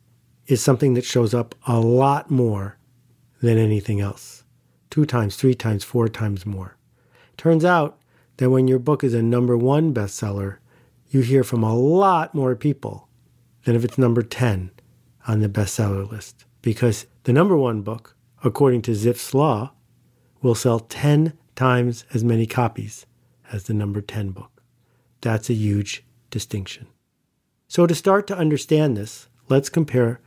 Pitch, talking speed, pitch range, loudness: 120 Hz, 155 wpm, 115-130 Hz, -21 LUFS